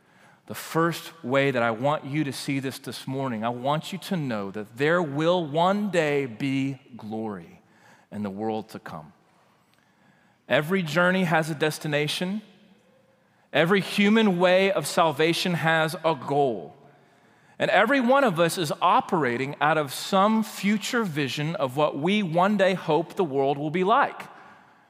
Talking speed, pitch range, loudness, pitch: 155 wpm, 140-185 Hz, -24 LUFS, 160 Hz